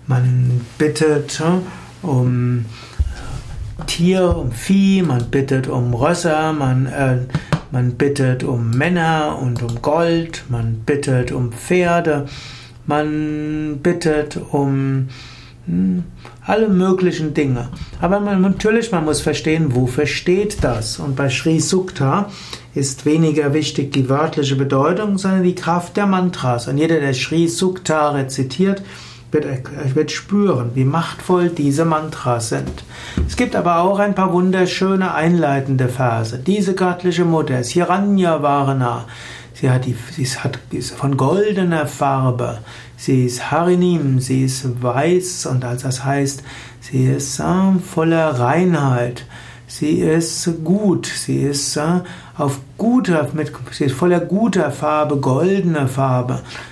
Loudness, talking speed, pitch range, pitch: -17 LUFS, 130 wpm, 130-170 Hz, 150 Hz